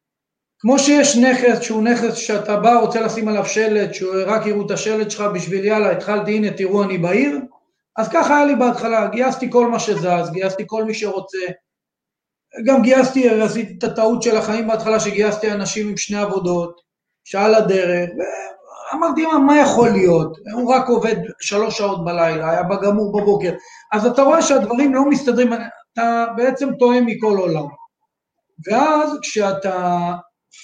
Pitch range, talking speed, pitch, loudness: 195-245 Hz, 155 wpm, 220 Hz, -17 LUFS